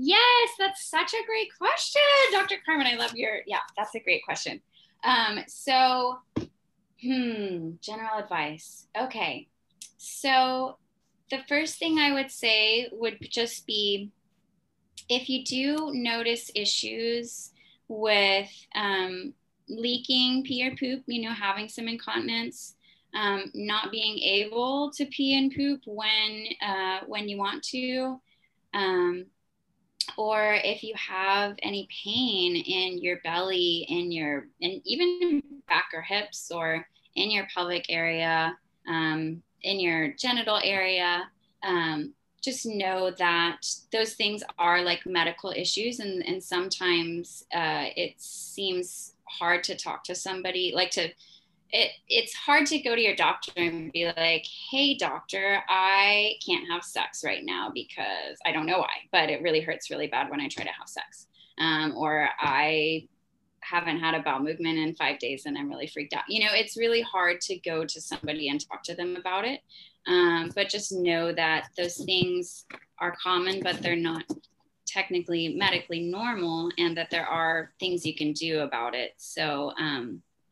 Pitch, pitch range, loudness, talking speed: 200 Hz, 175-245 Hz, -27 LUFS, 155 wpm